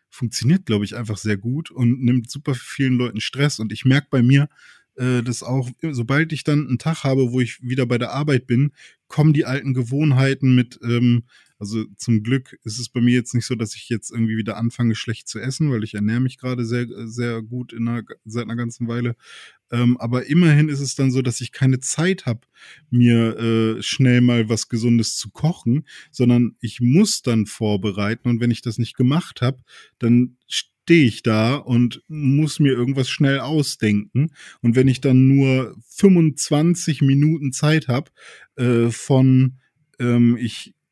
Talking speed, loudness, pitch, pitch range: 185 wpm, -20 LUFS, 125 Hz, 120-140 Hz